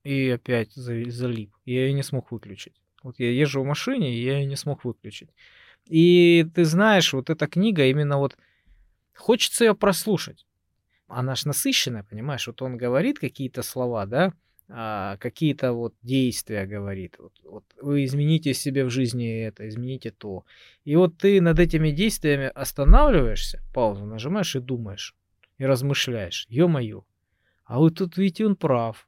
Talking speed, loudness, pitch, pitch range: 155 wpm, -23 LUFS, 130 Hz, 115-155 Hz